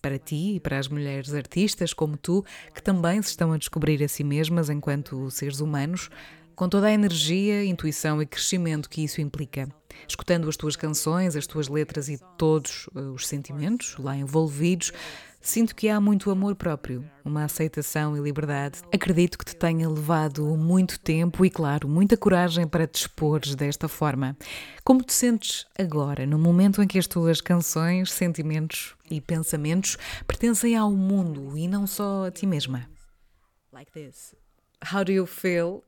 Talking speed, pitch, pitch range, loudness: 155 wpm, 160 Hz, 150-185 Hz, -25 LUFS